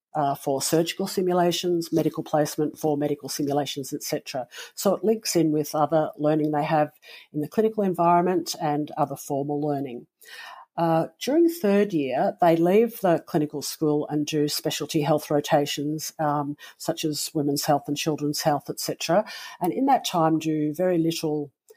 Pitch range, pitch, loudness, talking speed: 145-170 Hz, 155 Hz, -24 LUFS, 155 wpm